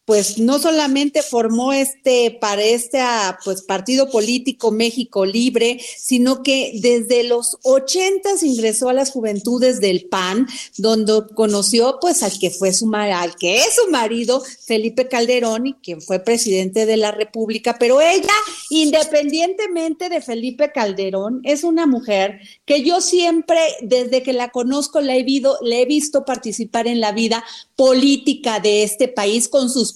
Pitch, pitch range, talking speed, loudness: 245 Hz, 220-275 Hz, 150 wpm, -17 LUFS